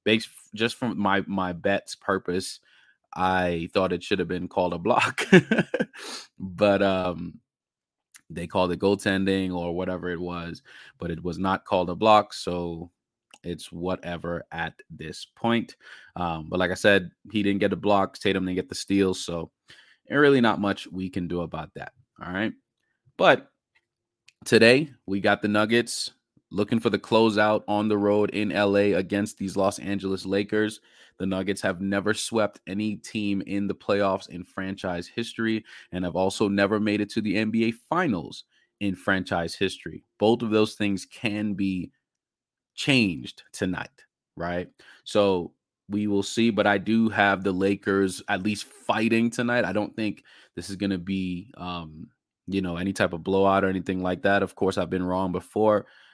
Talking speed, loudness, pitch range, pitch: 170 wpm, -25 LUFS, 90-105 Hz, 100 Hz